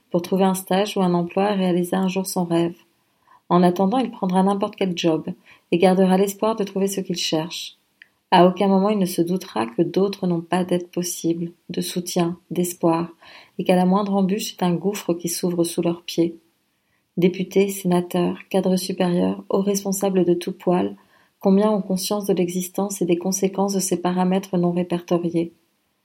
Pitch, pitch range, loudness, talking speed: 185 Hz, 175-195 Hz, -21 LUFS, 180 wpm